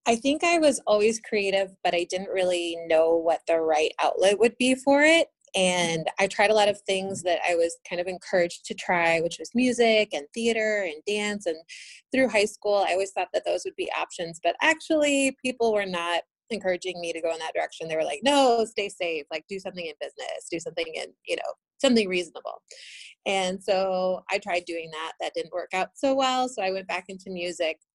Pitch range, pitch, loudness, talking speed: 175-235 Hz, 195 Hz, -25 LUFS, 215 wpm